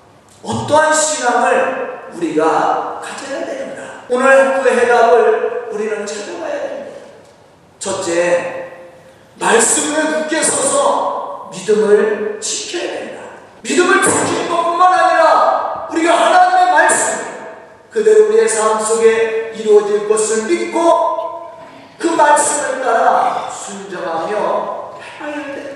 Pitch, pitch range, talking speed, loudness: 285 Hz, 220-335 Hz, 240 characters per minute, -14 LUFS